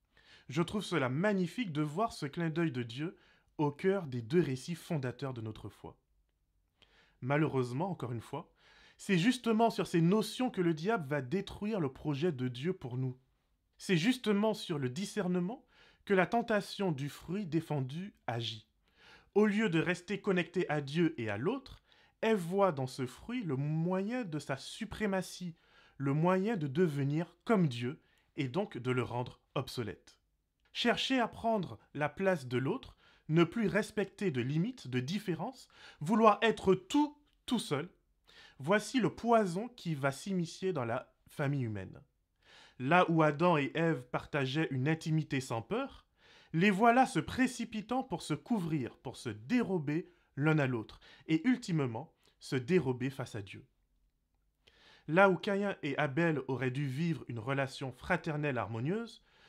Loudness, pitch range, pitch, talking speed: -34 LUFS, 135-200 Hz, 165 Hz, 155 wpm